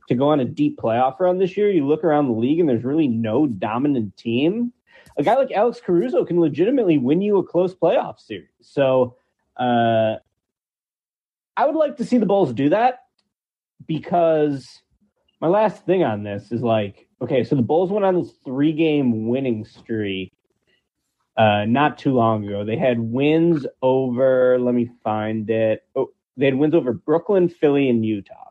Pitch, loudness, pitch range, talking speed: 140 Hz, -20 LUFS, 115-170 Hz, 180 wpm